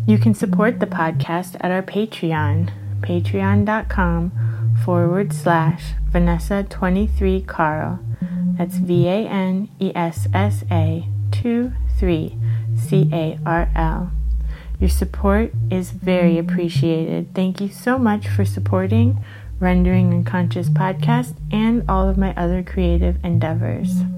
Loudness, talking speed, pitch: -19 LUFS, 115 wpm, 155 Hz